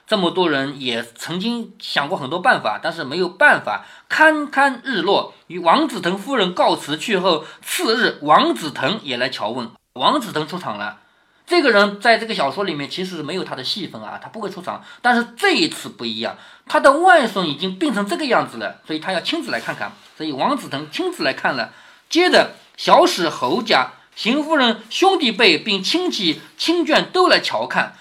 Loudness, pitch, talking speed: -18 LUFS, 235 Hz, 285 characters per minute